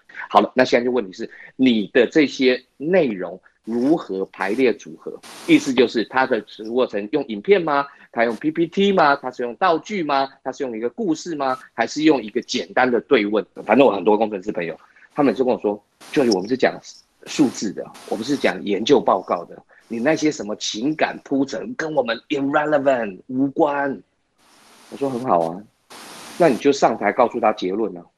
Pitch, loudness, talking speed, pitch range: 135 Hz, -20 LUFS, 295 characters per minute, 115-150 Hz